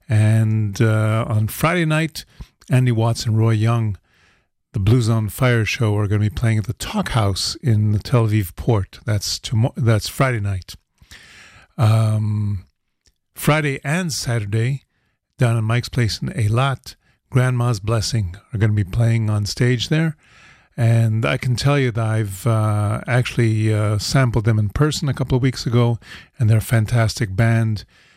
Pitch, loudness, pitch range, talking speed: 115 Hz, -19 LUFS, 105-125 Hz, 165 wpm